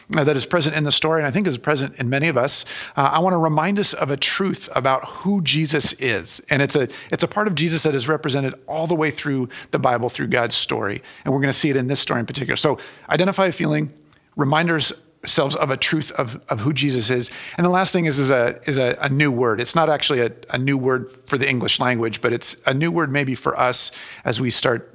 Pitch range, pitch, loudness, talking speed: 135-165 Hz, 150 Hz, -19 LUFS, 260 wpm